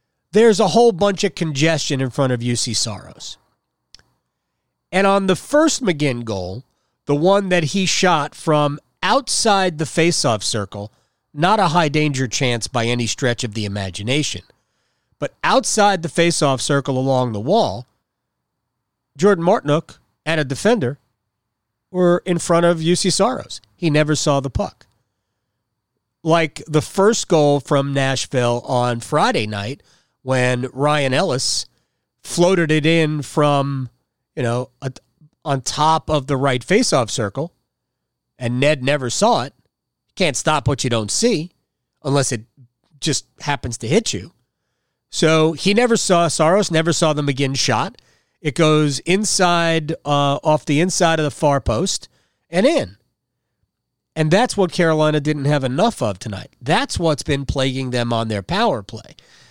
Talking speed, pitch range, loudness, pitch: 145 wpm, 125-170 Hz, -18 LUFS, 145 Hz